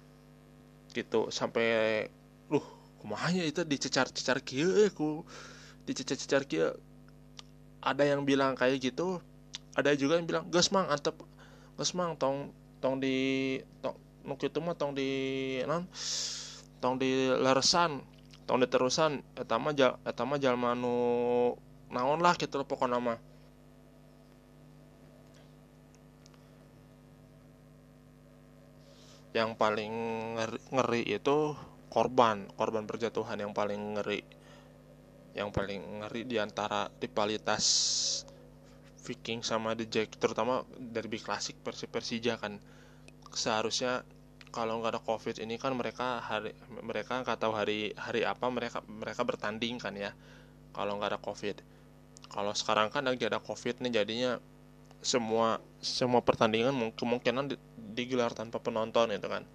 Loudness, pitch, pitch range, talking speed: -32 LUFS, 120 Hz, 110-135 Hz, 115 wpm